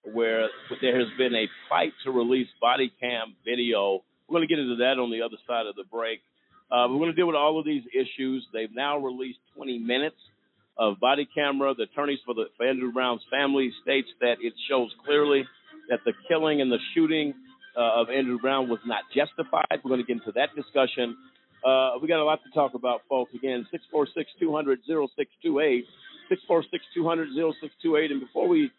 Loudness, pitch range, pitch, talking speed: -26 LUFS, 125-155 Hz, 135 Hz, 190 wpm